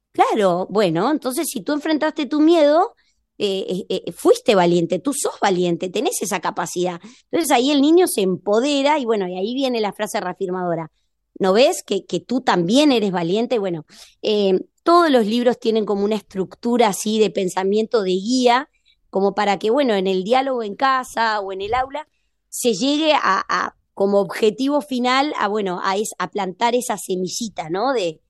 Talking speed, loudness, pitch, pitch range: 180 wpm, -19 LUFS, 215 Hz, 190-255 Hz